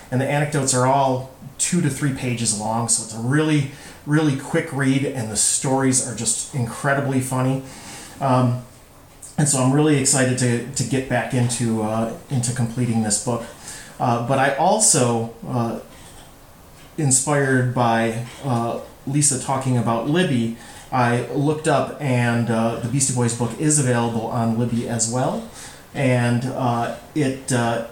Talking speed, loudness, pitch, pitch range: 155 wpm, -20 LUFS, 125 Hz, 115-135 Hz